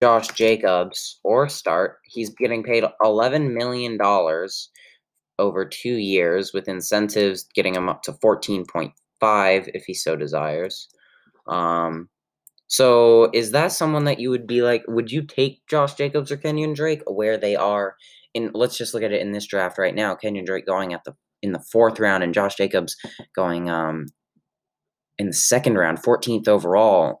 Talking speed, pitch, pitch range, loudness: 170 wpm, 110 Hz, 95-125 Hz, -21 LUFS